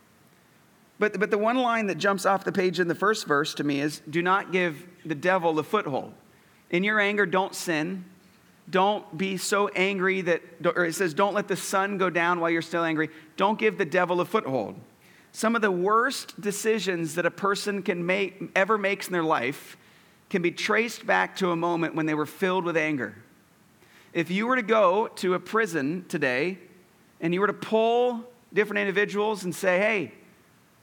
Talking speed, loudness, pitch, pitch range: 195 wpm, -25 LUFS, 190 Hz, 175-210 Hz